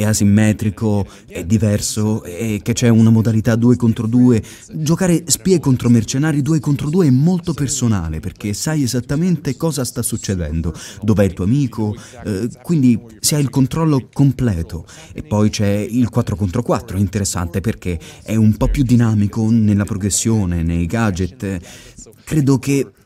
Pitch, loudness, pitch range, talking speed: 115 Hz, -17 LUFS, 105-130 Hz, 155 wpm